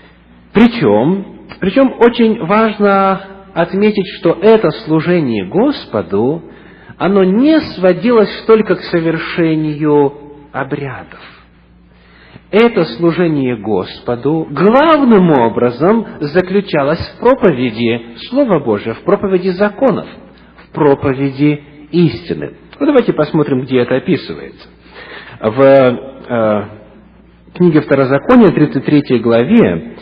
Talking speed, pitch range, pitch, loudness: 90 wpm, 130-195 Hz, 160 Hz, -12 LUFS